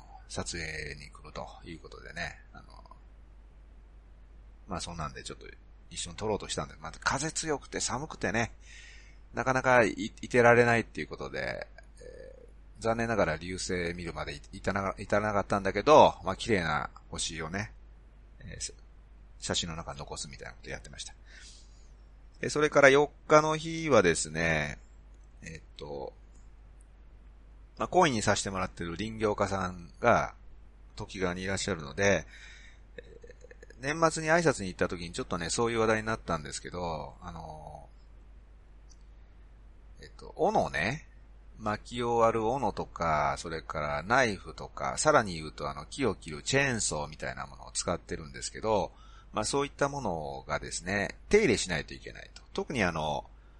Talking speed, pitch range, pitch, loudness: 315 characters per minute, 80-120 Hz, 95 Hz, -30 LUFS